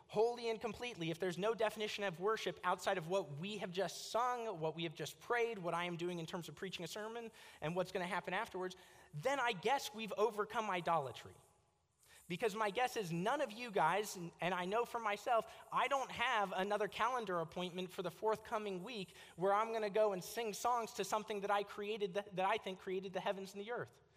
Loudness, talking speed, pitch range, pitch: -40 LUFS, 225 wpm, 180-220 Hz, 200 Hz